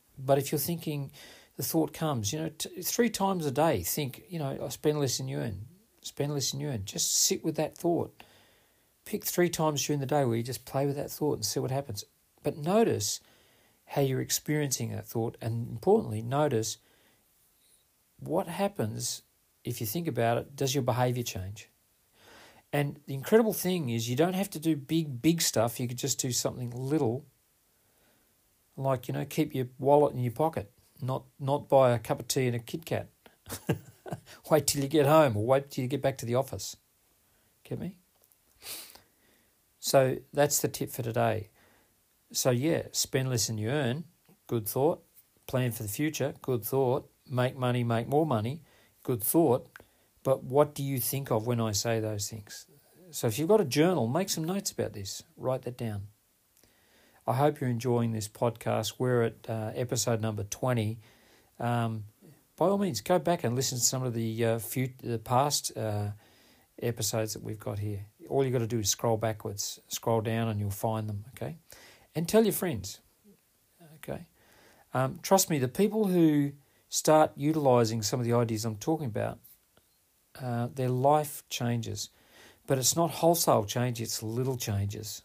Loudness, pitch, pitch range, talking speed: -30 LUFS, 125 Hz, 115-150 Hz, 180 wpm